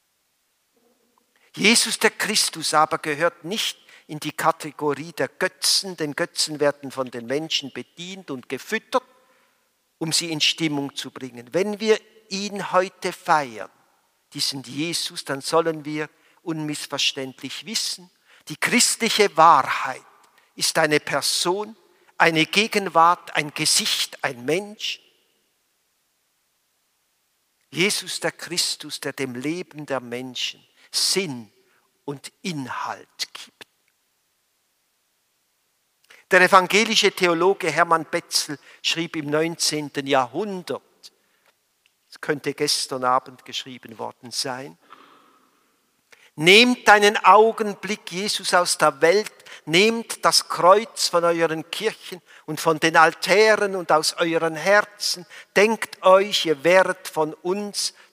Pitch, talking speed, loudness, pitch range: 165 Hz, 110 wpm, -21 LUFS, 150-195 Hz